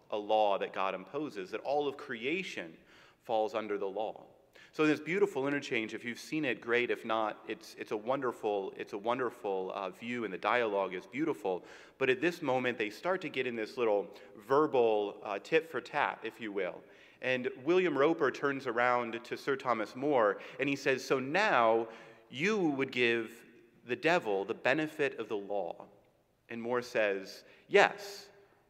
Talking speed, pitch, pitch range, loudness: 180 wpm, 120 Hz, 110-140 Hz, -33 LUFS